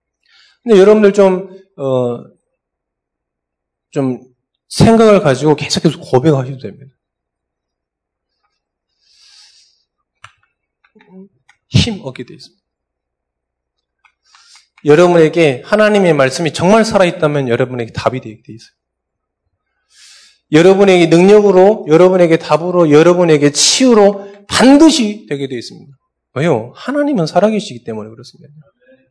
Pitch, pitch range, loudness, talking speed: 155 Hz, 125-195 Hz, -11 LUFS, 255 characters per minute